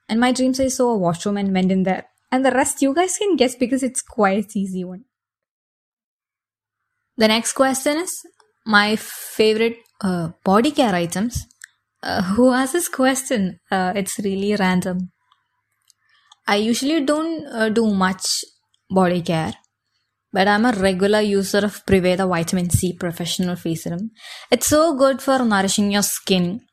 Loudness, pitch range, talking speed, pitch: -19 LUFS, 185-260 Hz, 155 wpm, 210 Hz